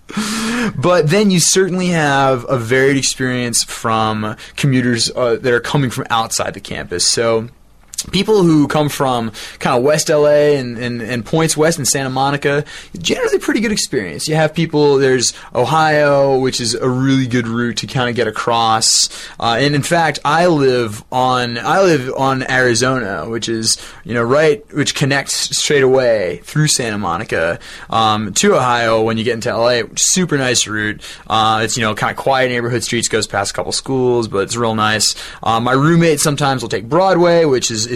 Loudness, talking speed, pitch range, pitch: -15 LUFS, 190 wpm, 115-155 Hz, 130 Hz